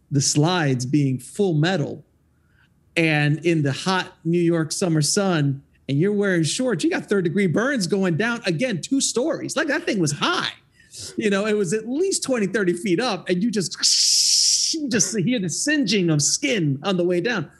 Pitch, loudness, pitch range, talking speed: 180 Hz, -20 LUFS, 155-210 Hz, 190 wpm